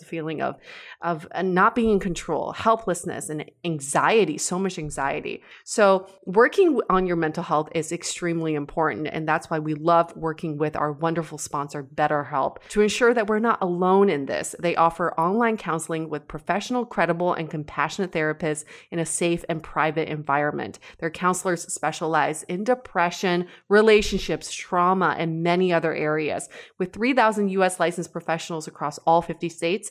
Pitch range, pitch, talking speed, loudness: 155-185 Hz, 170 Hz, 155 wpm, -24 LUFS